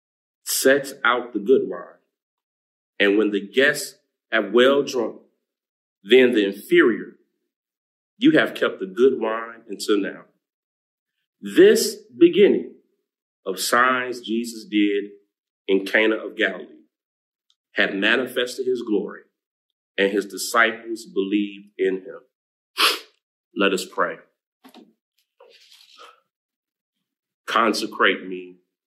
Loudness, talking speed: -20 LUFS, 100 wpm